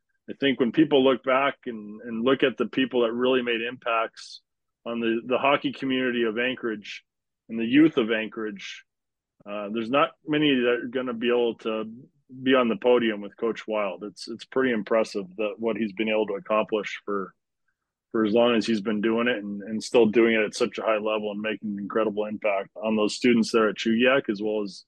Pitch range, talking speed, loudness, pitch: 110-125 Hz, 215 wpm, -25 LUFS, 115 Hz